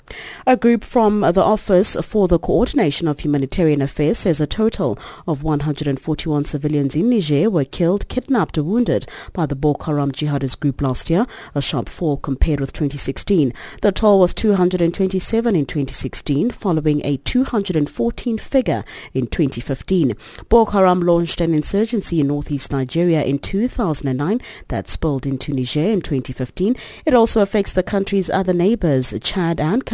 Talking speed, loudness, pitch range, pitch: 150 wpm, -19 LUFS, 145-205 Hz, 165 Hz